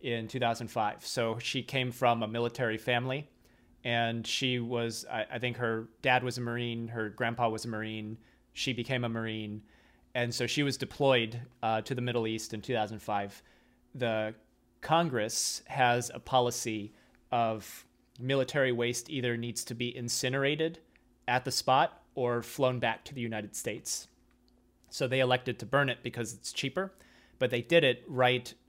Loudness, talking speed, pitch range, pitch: -32 LUFS, 165 wpm, 115-125 Hz, 120 Hz